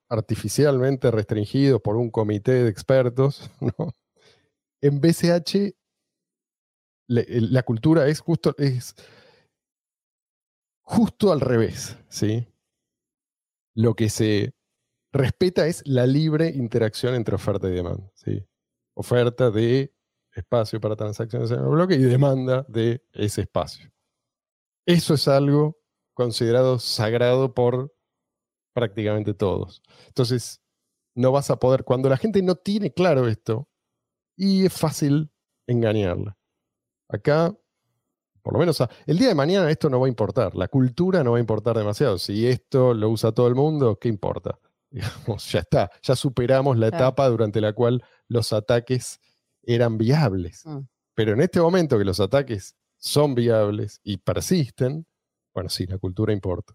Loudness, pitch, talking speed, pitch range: -22 LUFS, 125 Hz, 135 wpm, 110-140 Hz